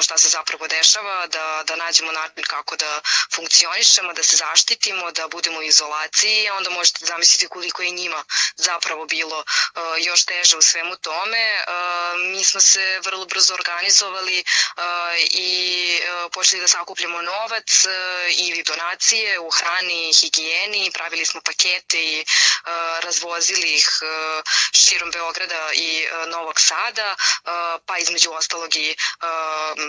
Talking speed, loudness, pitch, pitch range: 125 wpm, -17 LUFS, 170 Hz, 160-180 Hz